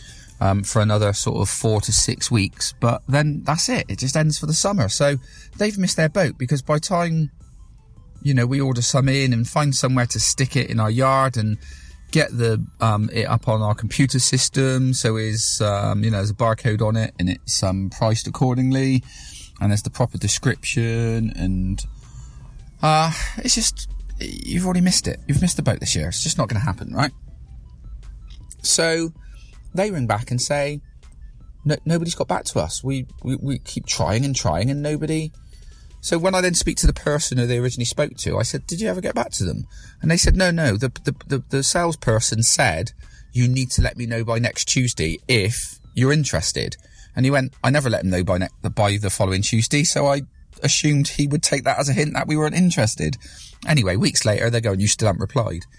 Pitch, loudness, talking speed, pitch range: 125 Hz, -20 LUFS, 210 wpm, 110-145 Hz